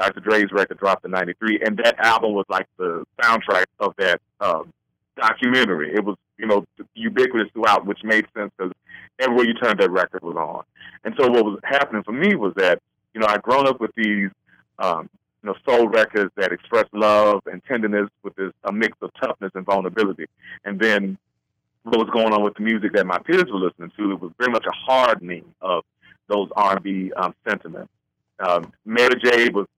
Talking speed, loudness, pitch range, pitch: 195 wpm, -20 LUFS, 95-125 Hz, 110 Hz